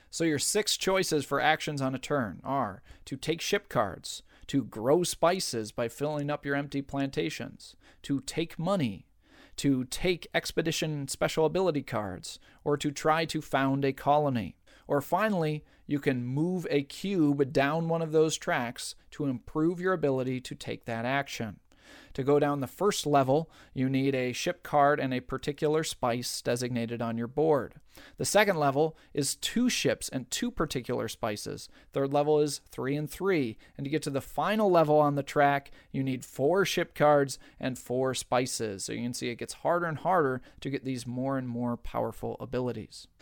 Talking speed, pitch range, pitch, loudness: 180 wpm, 130-155 Hz, 145 Hz, -29 LUFS